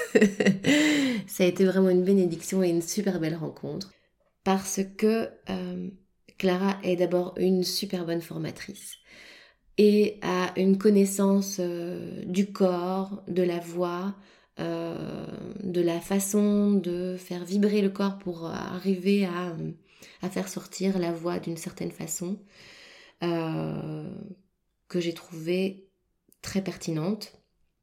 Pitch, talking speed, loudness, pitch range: 185 Hz, 125 wpm, -27 LUFS, 175-195 Hz